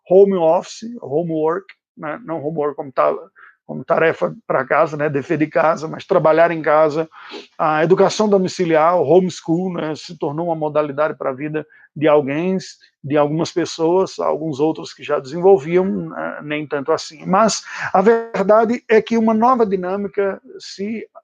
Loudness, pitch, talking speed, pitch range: -18 LUFS, 165 Hz, 155 wpm, 155-195 Hz